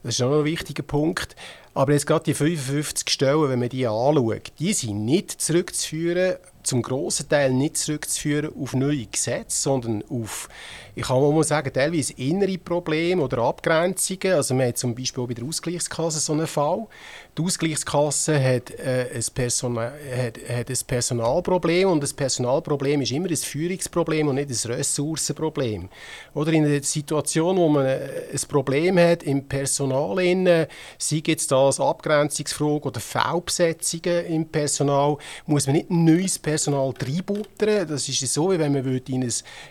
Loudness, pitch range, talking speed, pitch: -23 LUFS, 130-165 Hz, 160 wpm, 150 Hz